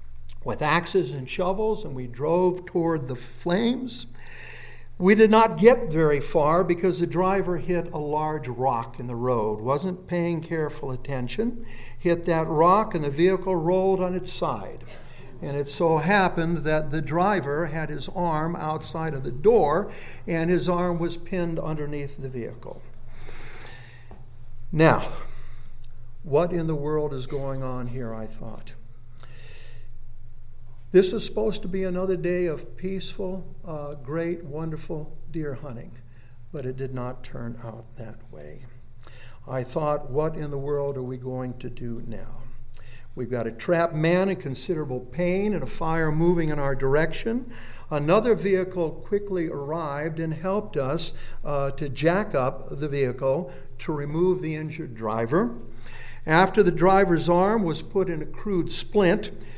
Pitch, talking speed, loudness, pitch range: 155 Hz, 150 wpm, -25 LUFS, 125-175 Hz